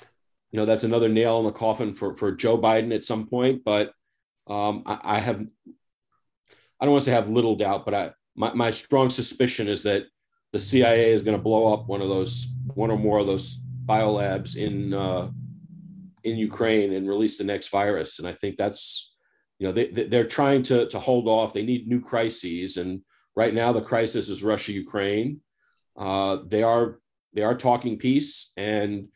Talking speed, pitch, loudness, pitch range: 195 wpm, 110 Hz, -24 LUFS, 105-120 Hz